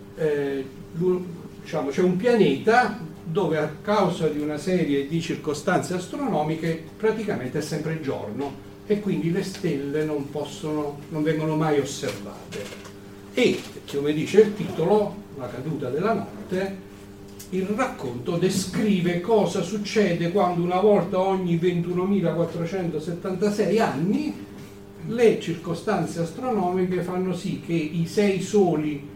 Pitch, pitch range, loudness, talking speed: 175 Hz, 155-195 Hz, -24 LUFS, 115 wpm